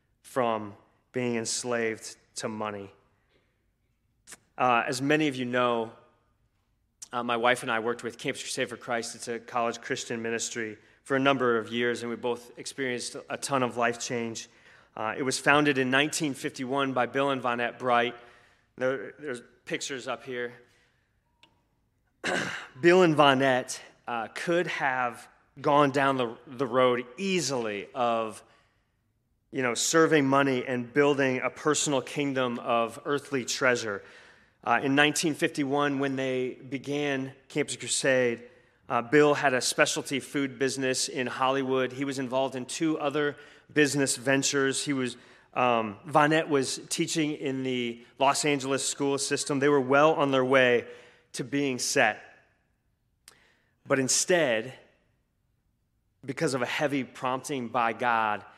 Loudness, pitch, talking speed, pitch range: -27 LUFS, 130 Hz, 140 wpm, 120-140 Hz